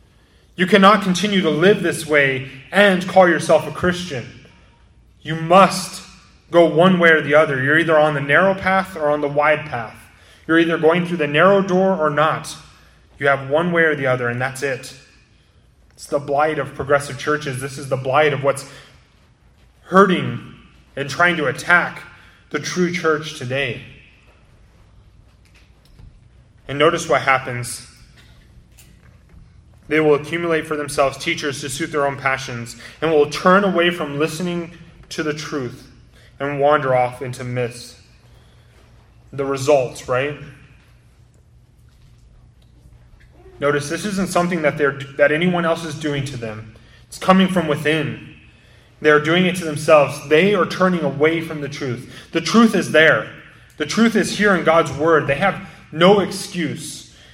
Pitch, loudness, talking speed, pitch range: 150 Hz, -17 LUFS, 155 wpm, 135-170 Hz